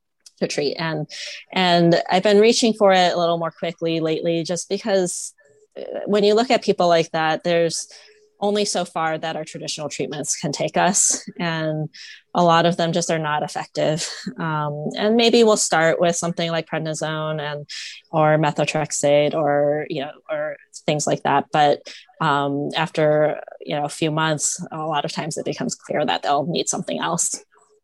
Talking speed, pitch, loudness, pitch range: 175 wpm, 165 Hz, -20 LUFS, 155-195 Hz